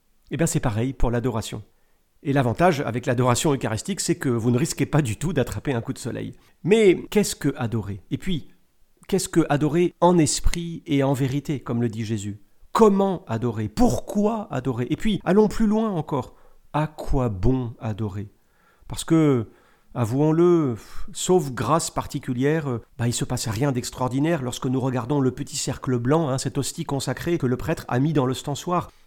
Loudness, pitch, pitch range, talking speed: -23 LUFS, 140 Hz, 120-165 Hz, 180 wpm